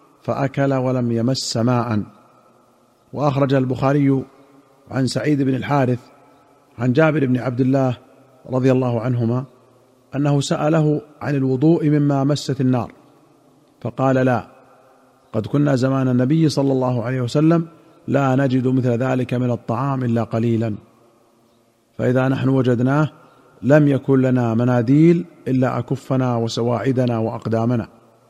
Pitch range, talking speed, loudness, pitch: 120-140 Hz, 115 wpm, -19 LUFS, 130 Hz